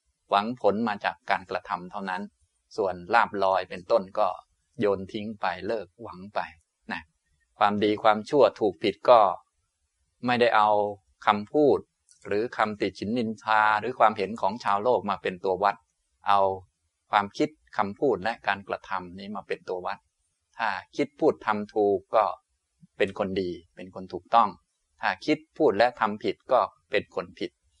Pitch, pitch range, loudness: 100 Hz, 90-105 Hz, -26 LUFS